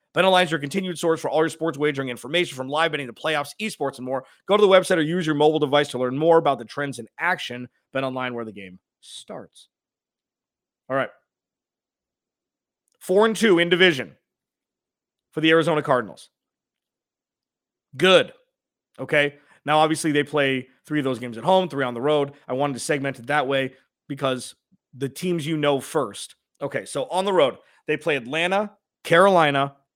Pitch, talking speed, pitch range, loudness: 150 Hz, 180 wpm, 135-170 Hz, -22 LUFS